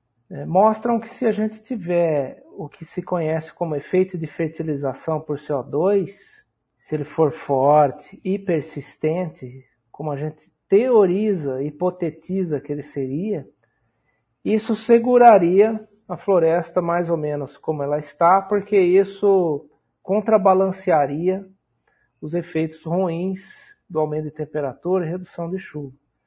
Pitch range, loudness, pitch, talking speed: 150-195 Hz, -21 LUFS, 170 Hz, 125 wpm